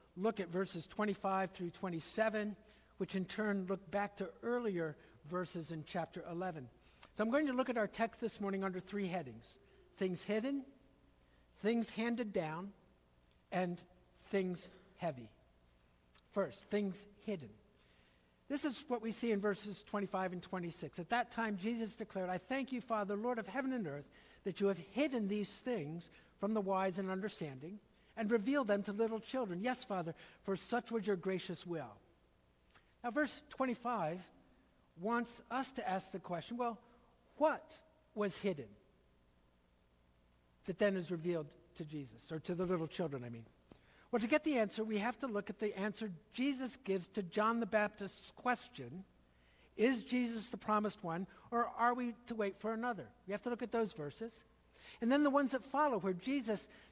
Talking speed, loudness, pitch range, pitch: 170 wpm, -40 LUFS, 175-230 Hz, 200 Hz